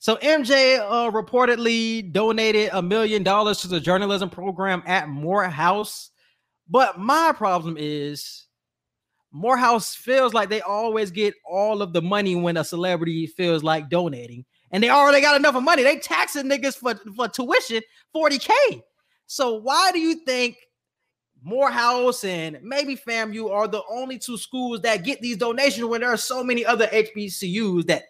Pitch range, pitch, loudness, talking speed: 190-255 Hz, 220 Hz, -21 LUFS, 160 wpm